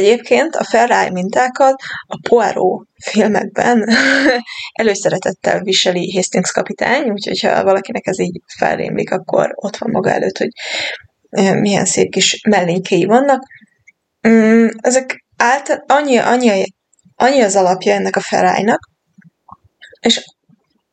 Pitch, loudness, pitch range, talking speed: 220 Hz, -14 LUFS, 190-250 Hz, 110 wpm